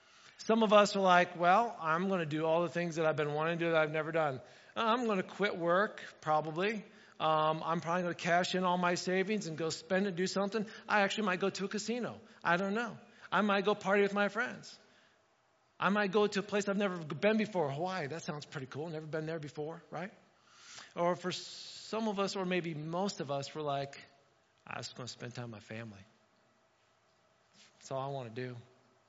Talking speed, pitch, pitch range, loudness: 225 wpm, 175 Hz, 155-200 Hz, -33 LUFS